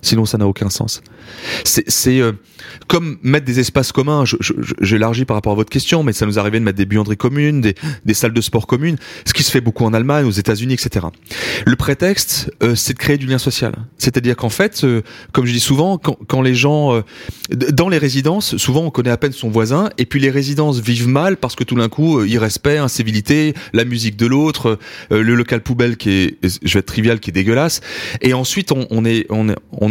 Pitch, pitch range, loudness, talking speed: 125 Hz, 110-140 Hz, -15 LUFS, 235 wpm